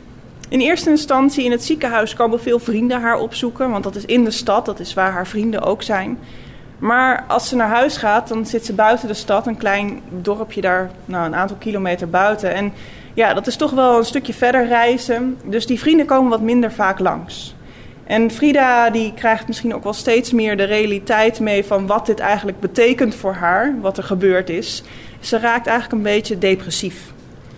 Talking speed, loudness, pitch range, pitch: 200 wpm, -17 LUFS, 195-240 Hz, 220 Hz